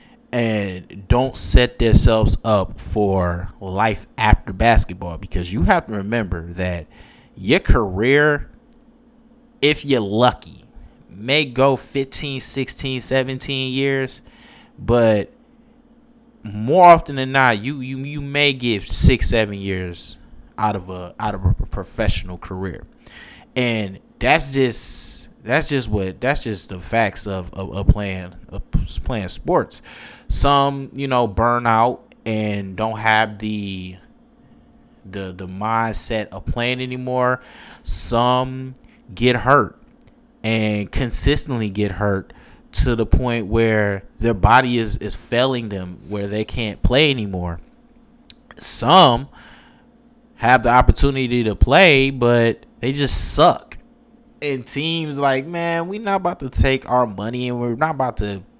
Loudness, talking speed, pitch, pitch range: -19 LUFS, 130 wpm, 115 Hz, 100-135 Hz